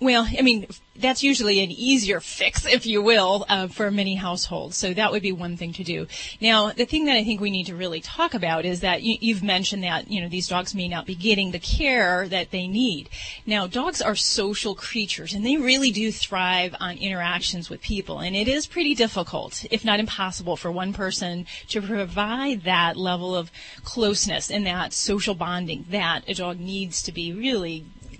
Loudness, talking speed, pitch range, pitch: -23 LUFS, 205 wpm, 180-220 Hz, 200 Hz